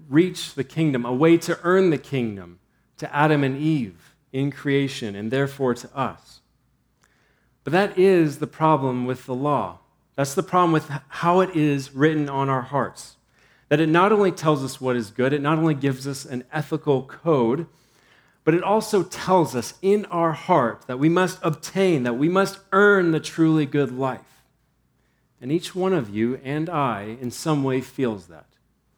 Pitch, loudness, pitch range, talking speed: 150 Hz, -22 LUFS, 130-165 Hz, 180 wpm